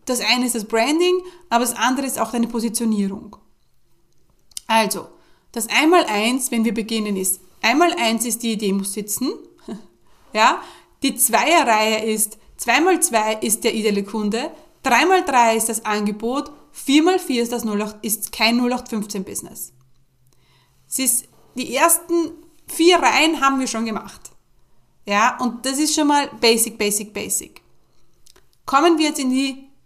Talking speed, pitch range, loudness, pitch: 160 wpm, 215-280 Hz, -19 LUFS, 235 Hz